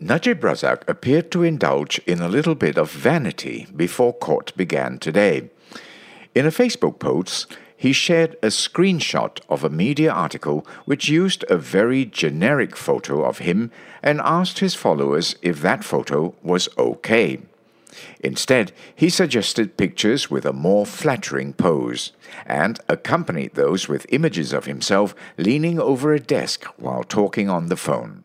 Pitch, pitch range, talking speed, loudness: 145 Hz, 105-165 Hz, 145 wpm, -20 LUFS